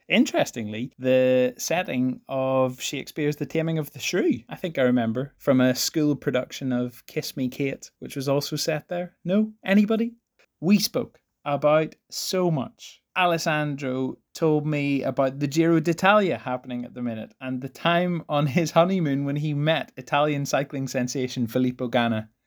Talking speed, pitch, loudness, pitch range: 160 wpm, 145 Hz, -24 LUFS, 130-165 Hz